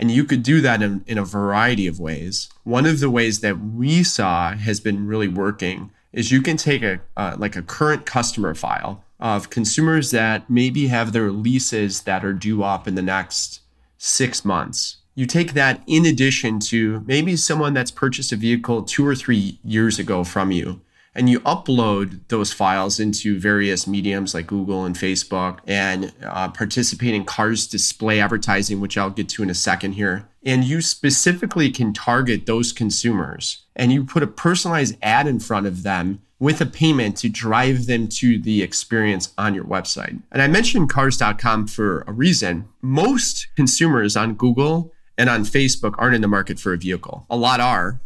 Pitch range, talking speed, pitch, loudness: 100-130 Hz, 185 wpm, 110 Hz, -19 LUFS